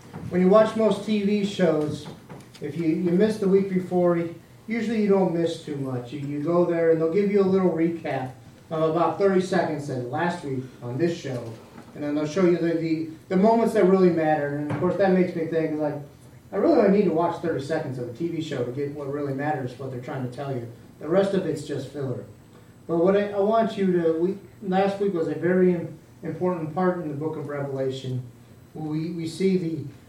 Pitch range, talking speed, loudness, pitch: 145-185 Hz, 225 wpm, -24 LUFS, 165 Hz